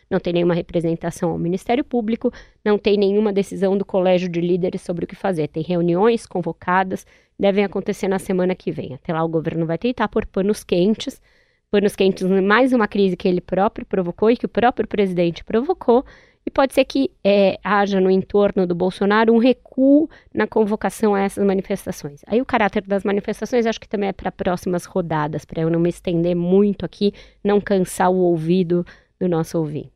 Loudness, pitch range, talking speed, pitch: -20 LUFS, 180-215 Hz, 190 wpm, 195 Hz